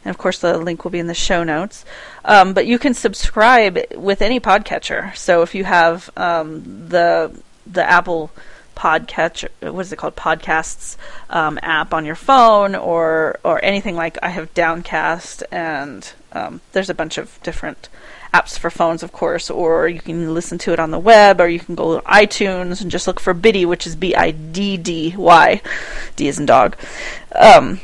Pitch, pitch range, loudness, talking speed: 175 Hz, 165-190 Hz, -15 LUFS, 185 wpm